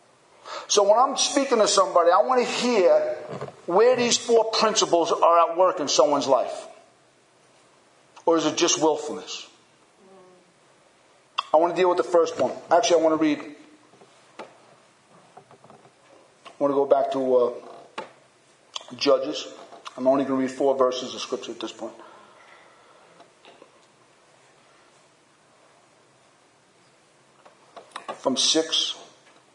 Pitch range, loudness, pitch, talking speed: 150-210 Hz, -22 LUFS, 170 Hz, 120 wpm